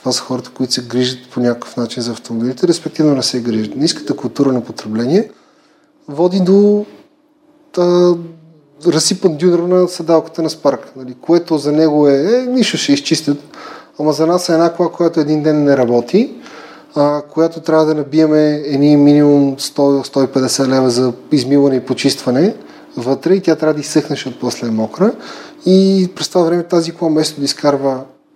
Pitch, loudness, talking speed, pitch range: 150 Hz, -14 LUFS, 165 wpm, 130-170 Hz